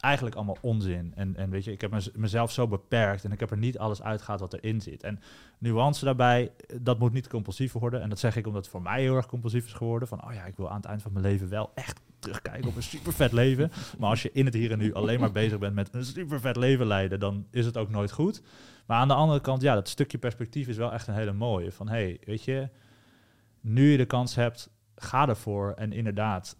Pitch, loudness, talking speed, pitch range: 115 Hz, -29 LUFS, 260 wpm, 105-125 Hz